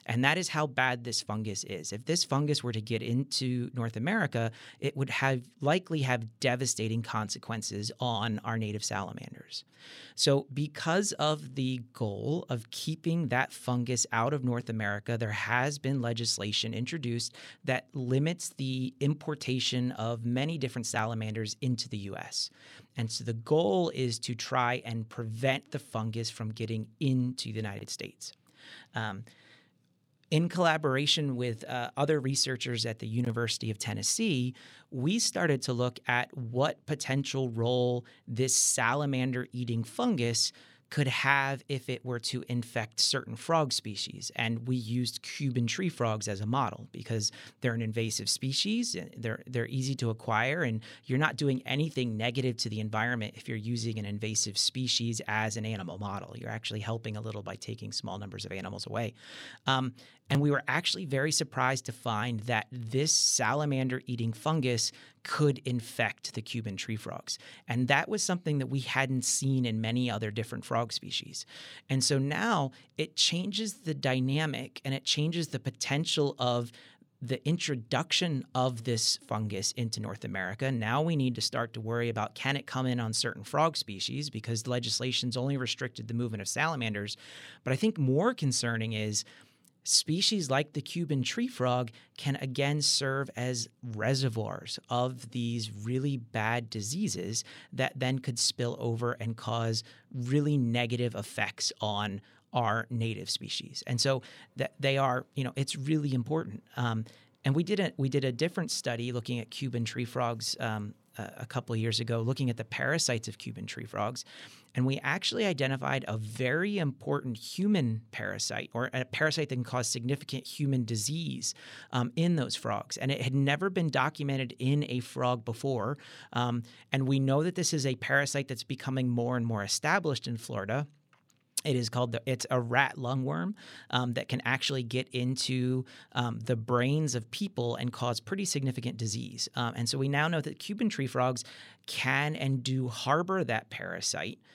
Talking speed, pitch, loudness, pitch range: 165 wpm, 125 Hz, -31 LUFS, 115-140 Hz